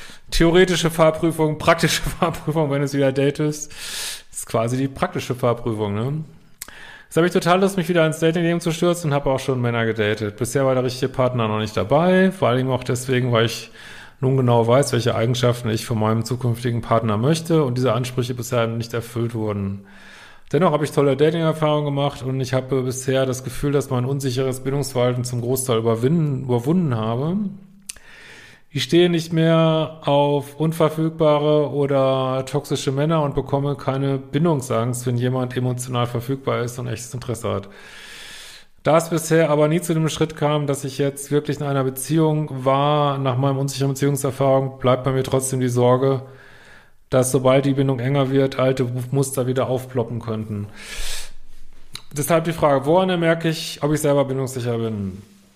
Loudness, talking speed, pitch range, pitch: -20 LUFS, 165 wpm, 125-155 Hz, 135 Hz